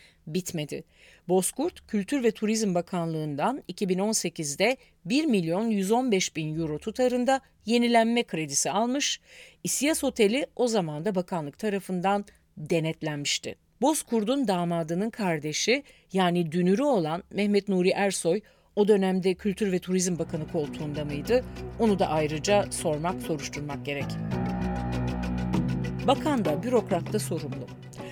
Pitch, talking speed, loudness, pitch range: 185 Hz, 110 wpm, -27 LUFS, 155-215 Hz